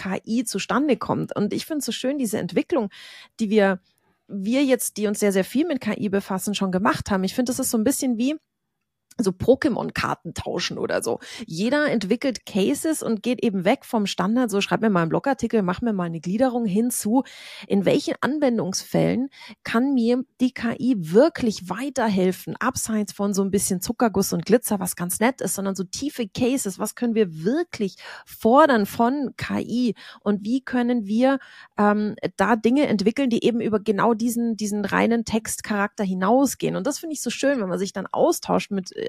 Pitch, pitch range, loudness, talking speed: 230 Hz, 200-255 Hz, -23 LUFS, 185 wpm